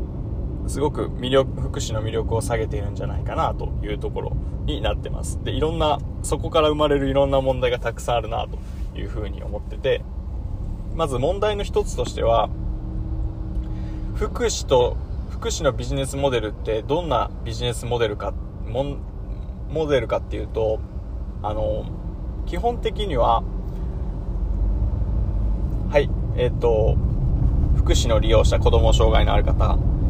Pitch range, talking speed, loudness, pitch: 90-135 Hz, 295 characters per minute, -23 LUFS, 110 Hz